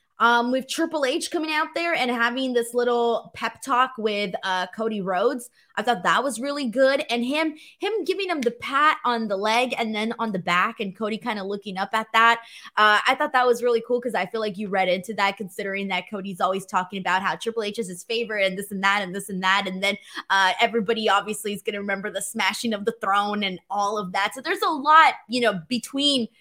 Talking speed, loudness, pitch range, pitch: 240 wpm, -23 LUFS, 200-245 Hz, 225 Hz